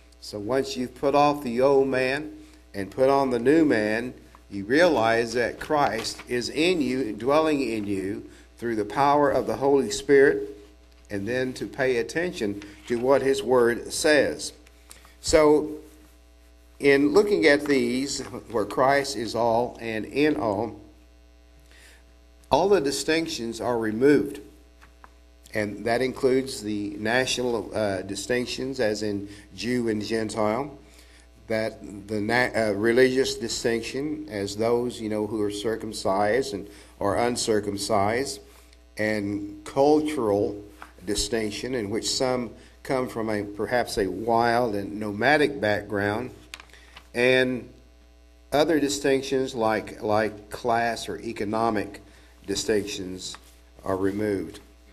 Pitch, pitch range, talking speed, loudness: 110 Hz, 100-130 Hz, 120 wpm, -24 LUFS